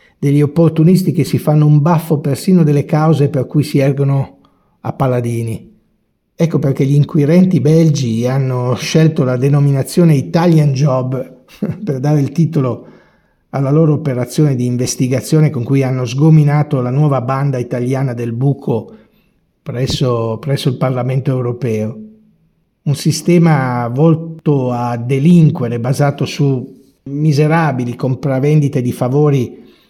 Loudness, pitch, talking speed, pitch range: -14 LUFS, 140 Hz, 125 wpm, 130-155 Hz